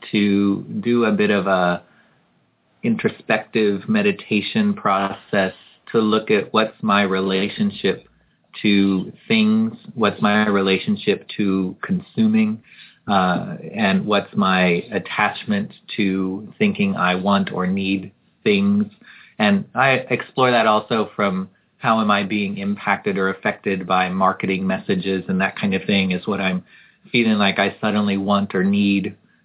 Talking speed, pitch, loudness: 130 wpm, 105 Hz, -20 LUFS